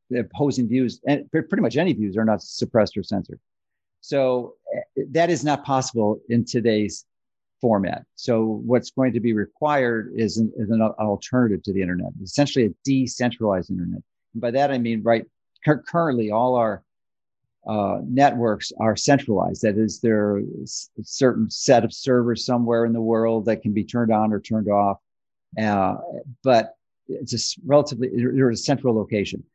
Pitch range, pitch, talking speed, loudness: 110-130 Hz, 115 Hz, 165 wpm, -22 LUFS